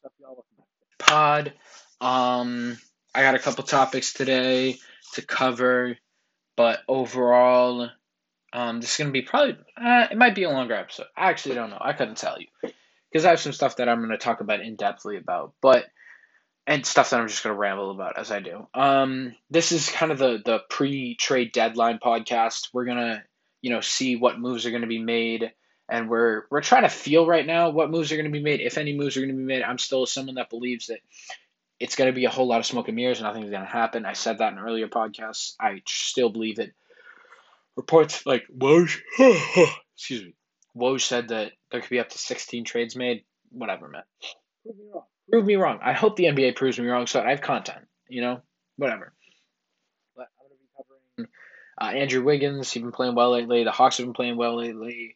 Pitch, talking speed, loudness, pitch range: 125 Hz, 200 wpm, -23 LUFS, 120-140 Hz